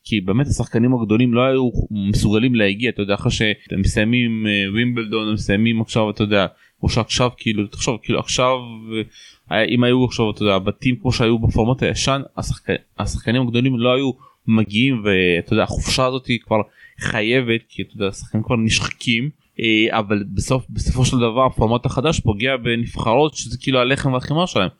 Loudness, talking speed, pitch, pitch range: -19 LUFS, 160 wpm, 115 Hz, 105-125 Hz